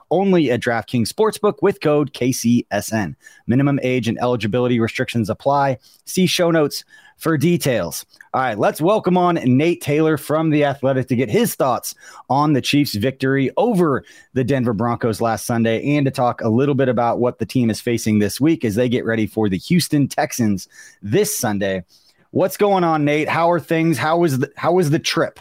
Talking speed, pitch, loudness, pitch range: 190 wpm, 135 Hz, -18 LUFS, 120-160 Hz